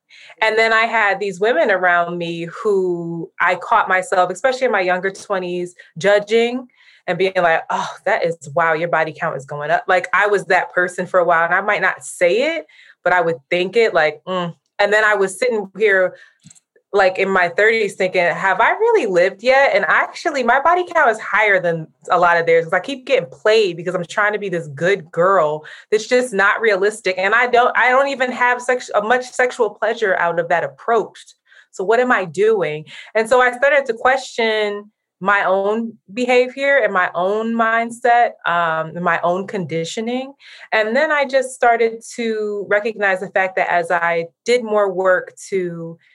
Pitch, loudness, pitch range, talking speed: 200 Hz, -17 LUFS, 180-235 Hz, 200 wpm